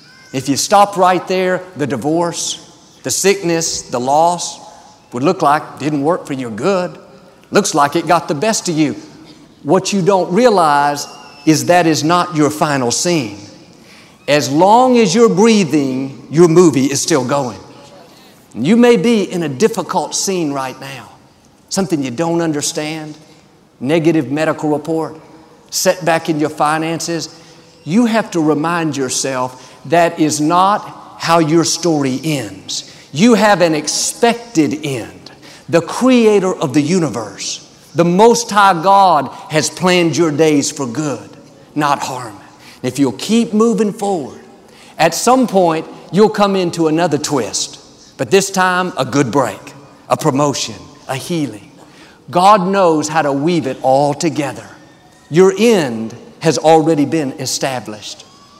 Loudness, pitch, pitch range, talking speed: -14 LUFS, 165 Hz, 145-185 Hz, 145 wpm